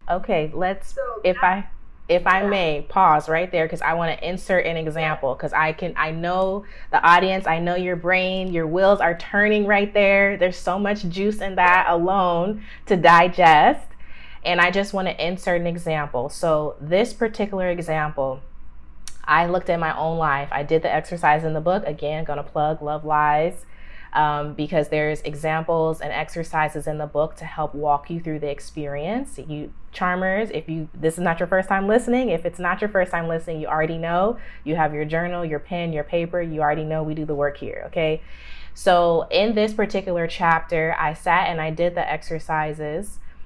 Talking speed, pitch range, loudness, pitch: 195 wpm, 155-185 Hz, -21 LUFS, 165 Hz